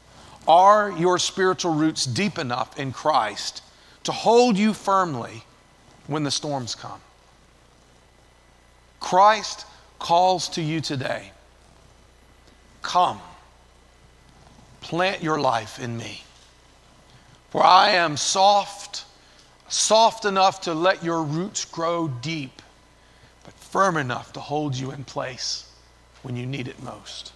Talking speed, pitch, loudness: 115 wpm, 140 Hz, -22 LUFS